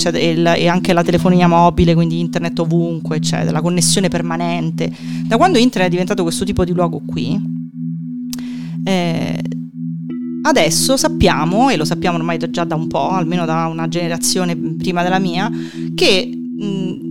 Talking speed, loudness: 145 wpm, -16 LUFS